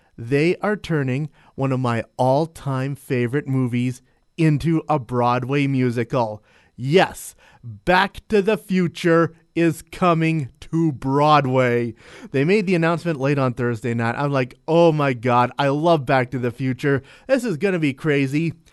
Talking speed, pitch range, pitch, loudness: 155 wpm, 125-165 Hz, 140 Hz, -20 LUFS